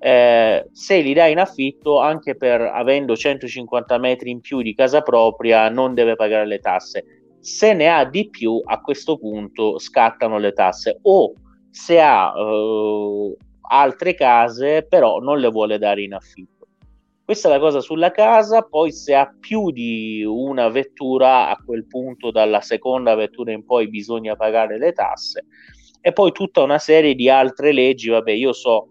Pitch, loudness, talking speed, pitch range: 125 Hz, -17 LUFS, 170 wpm, 110-150 Hz